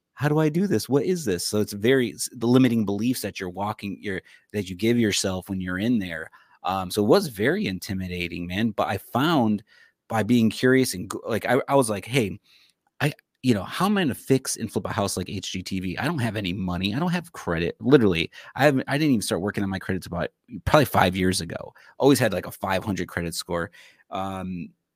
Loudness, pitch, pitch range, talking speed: -24 LUFS, 105 Hz, 95-120 Hz, 225 wpm